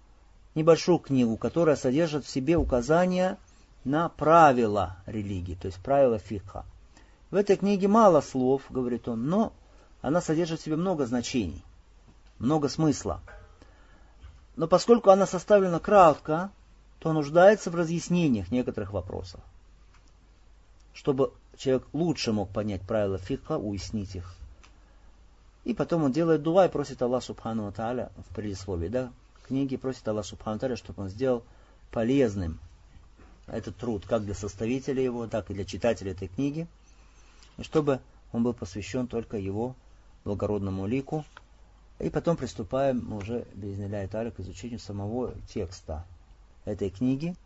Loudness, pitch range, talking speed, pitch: -27 LUFS, 95-145 Hz, 135 wpm, 115 Hz